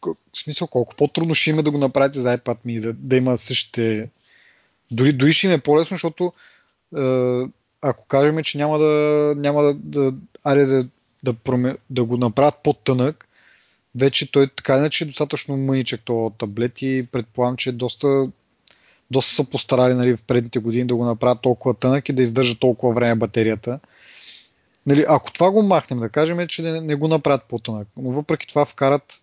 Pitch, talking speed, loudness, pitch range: 130 Hz, 180 wpm, -20 LUFS, 125-150 Hz